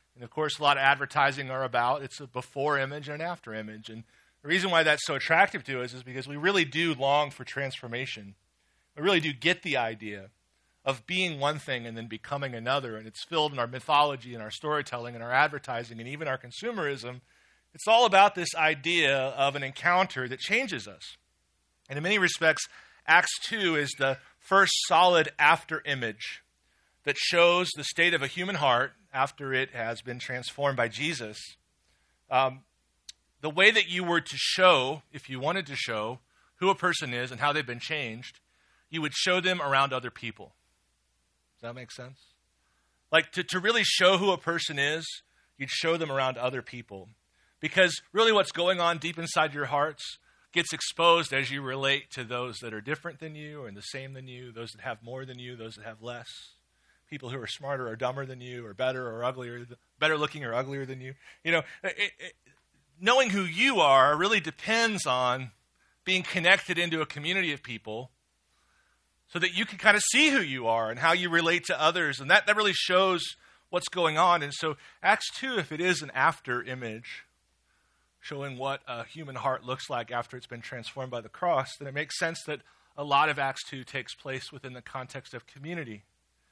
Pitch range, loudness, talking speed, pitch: 120-165 Hz, -27 LUFS, 200 wpm, 140 Hz